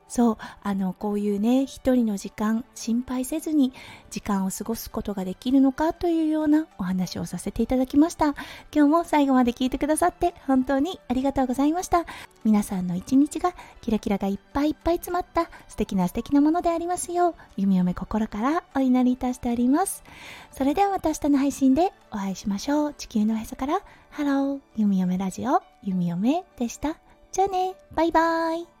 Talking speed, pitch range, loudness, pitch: 385 characters per minute, 215-320 Hz, -24 LUFS, 265 Hz